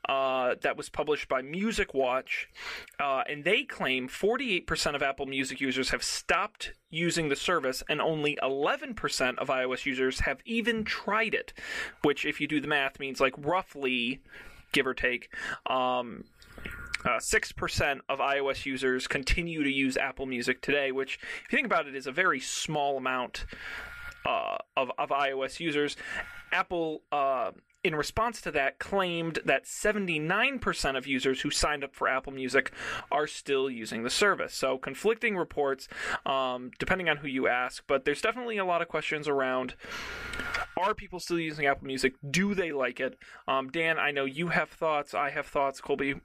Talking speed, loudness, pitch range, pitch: 170 wpm, -30 LUFS, 130-170 Hz, 140 Hz